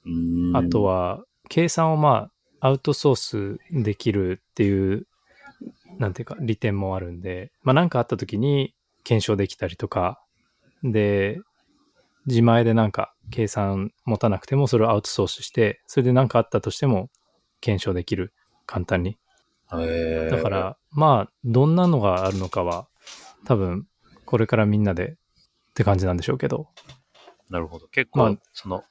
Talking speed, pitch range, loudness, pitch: 295 characters per minute, 95-130 Hz, -23 LUFS, 110 Hz